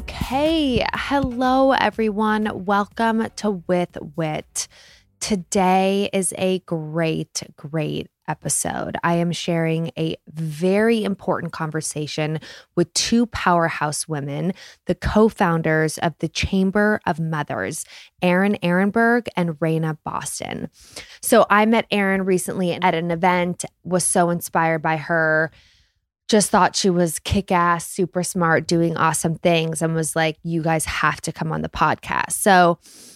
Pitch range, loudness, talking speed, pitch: 160-195 Hz, -20 LUFS, 130 wpm, 175 Hz